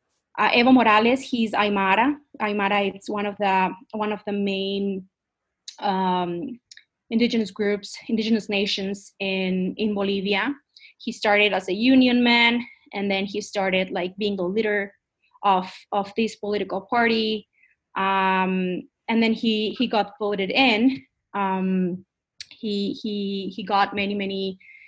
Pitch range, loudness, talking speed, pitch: 195-225 Hz, -23 LUFS, 135 wpm, 205 Hz